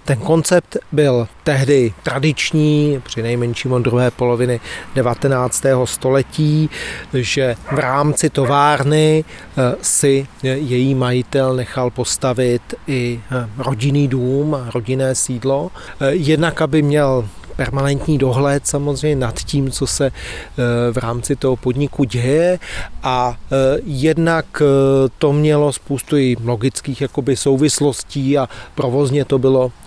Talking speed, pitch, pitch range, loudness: 110 wpm, 135 Hz, 125-145 Hz, -16 LUFS